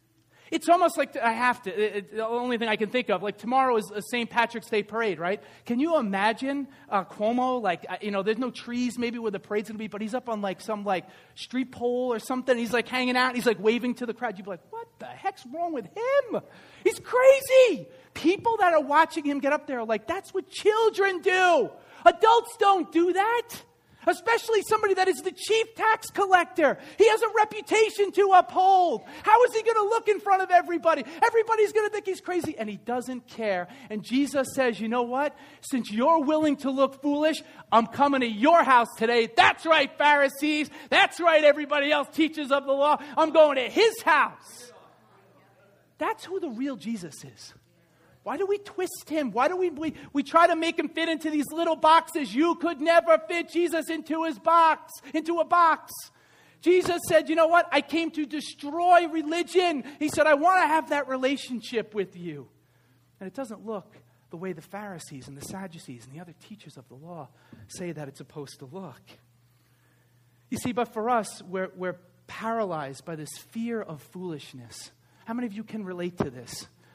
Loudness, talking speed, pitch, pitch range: -25 LUFS, 205 wpm, 275 Hz, 215-335 Hz